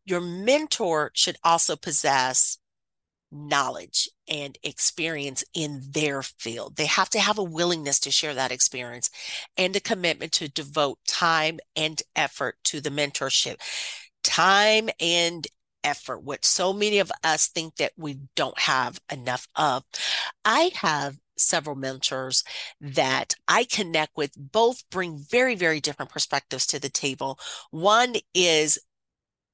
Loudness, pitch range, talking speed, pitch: -23 LUFS, 140-180 Hz, 135 wpm, 155 Hz